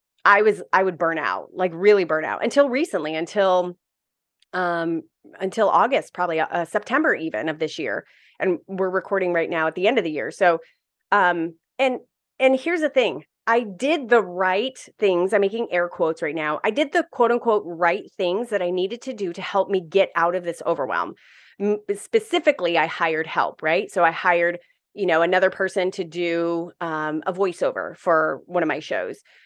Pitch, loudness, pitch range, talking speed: 185 Hz, -22 LUFS, 170-210 Hz, 190 wpm